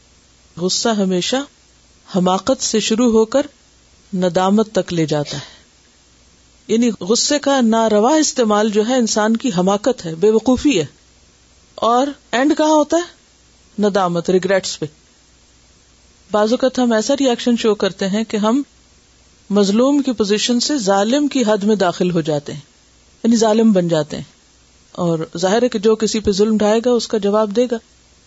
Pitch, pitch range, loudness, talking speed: 215 Hz, 175-240 Hz, -16 LUFS, 145 wpm